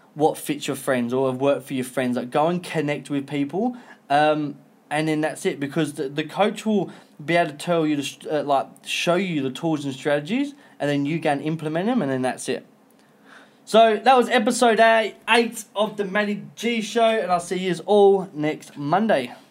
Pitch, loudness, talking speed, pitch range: 165 Hz, -22 LUFS, 210 wpm, 145-215 Hz